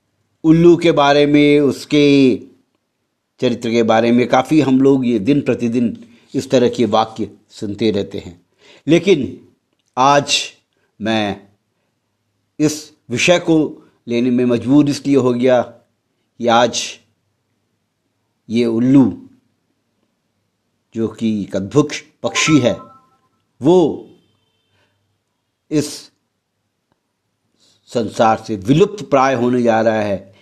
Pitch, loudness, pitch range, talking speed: 120 Hz, -15 LUFS, 110-140 Hz, 105 wpm